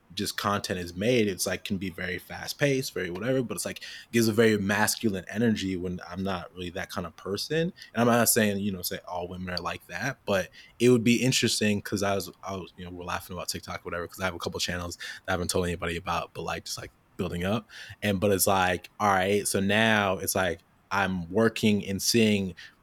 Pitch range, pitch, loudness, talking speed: 90-110 Hz, 100 Hz, -27 LUFS, 240 wpm